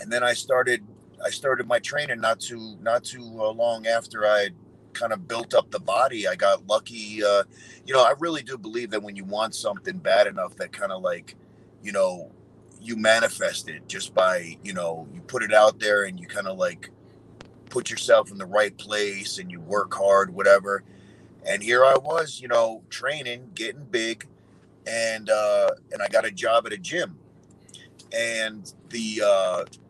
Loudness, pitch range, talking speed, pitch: -24 LUFS, 100-120 Hz, 190 wpm, 110 Hz